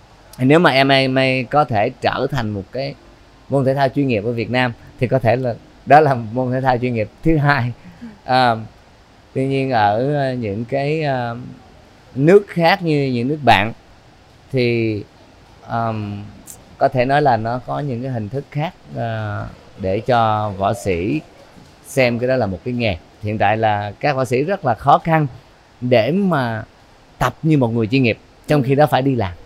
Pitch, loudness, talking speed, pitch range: 125 Hz, -18 LUFS, 180 wpm, 110-135 Hz